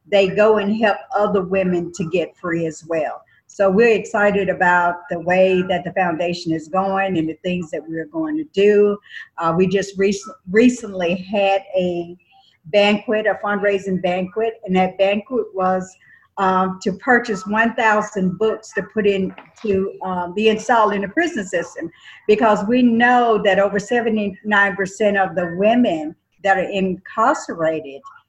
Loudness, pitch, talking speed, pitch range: -18 LUFS, 195 Hz, 155 wpm, 185-215 Hz